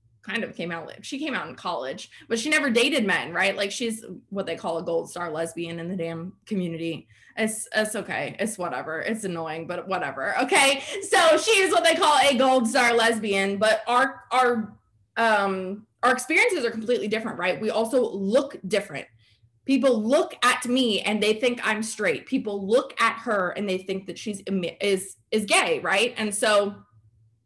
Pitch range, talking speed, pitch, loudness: 185-250 Hz, 190 wpm, 215 Hz, -24 LUFS